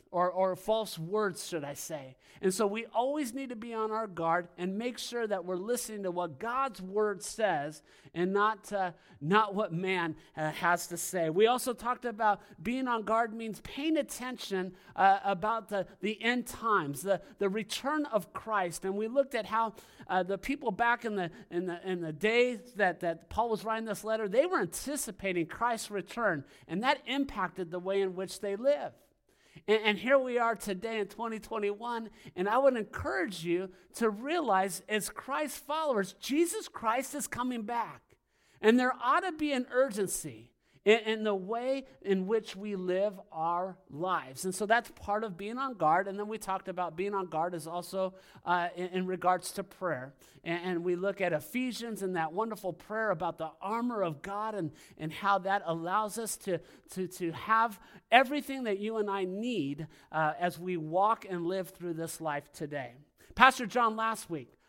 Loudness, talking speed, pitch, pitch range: -32 LUFS, 185 wpm, 205 Hz, 180-230 Hz